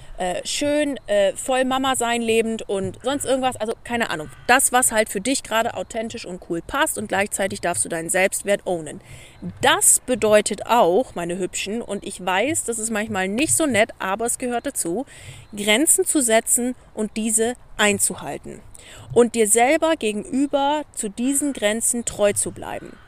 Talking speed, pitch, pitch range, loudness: 160 wpm, 225 Hz, 195-255 Hz, -20 LUFS